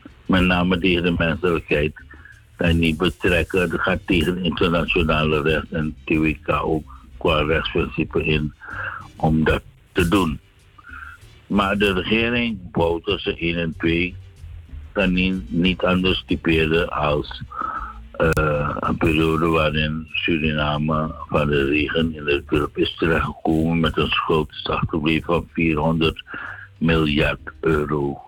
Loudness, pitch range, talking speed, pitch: -21 LUFS, 75-85 Hz, 120 wpm, 80 Hz